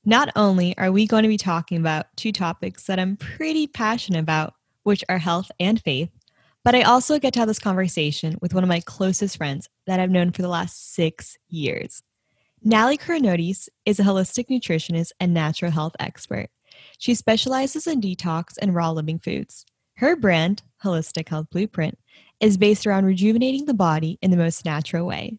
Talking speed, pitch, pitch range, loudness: 180 wpm, 185 Hz, 165-215 Hz, -22 LUFS